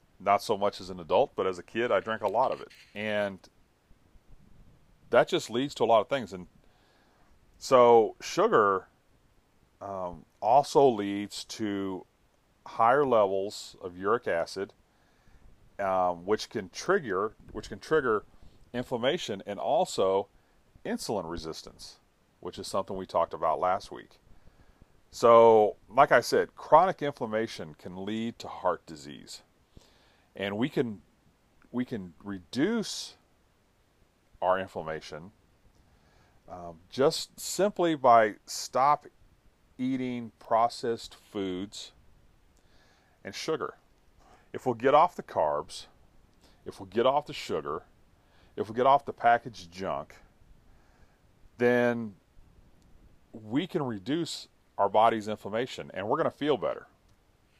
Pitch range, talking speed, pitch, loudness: 95-115 Hz, 125 wpm, 100 Hz, -28 LUFS